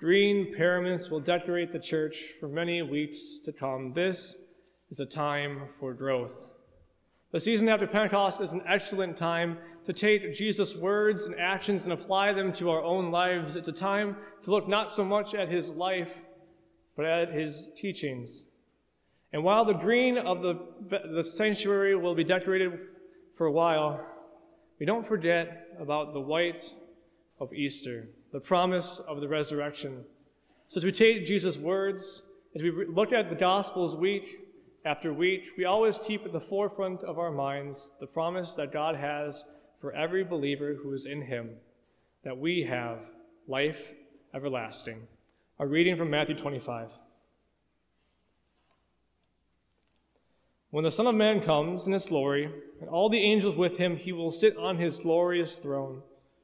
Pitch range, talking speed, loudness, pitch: 150-195 Hz, 155 wpm, -29 LUFS, 175 Hz